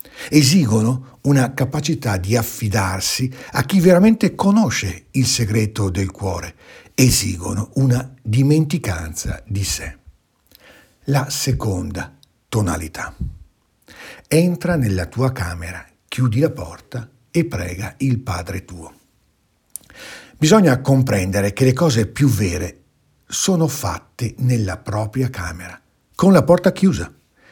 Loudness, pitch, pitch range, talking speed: -18 LUFS, 120 Hz, 95-140 Hz, 105 wpm